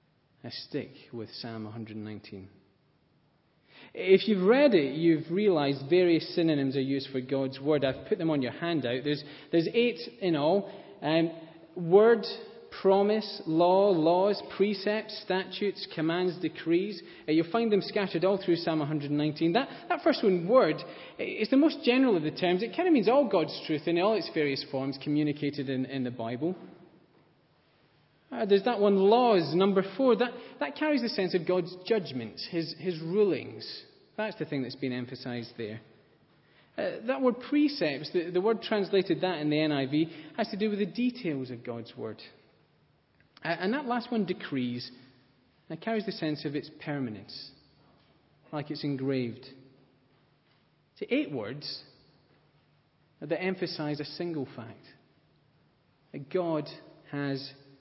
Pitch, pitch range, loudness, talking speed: 165 Hz, 140-200 Hz, -29 LUFS, 160 wpm